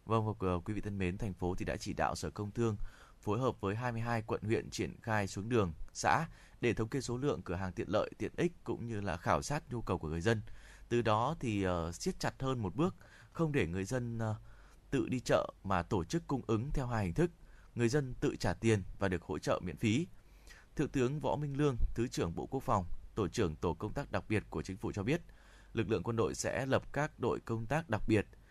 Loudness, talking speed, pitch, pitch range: -36 LUFS, 245 wpm, 110 Hz, 95-125 Hz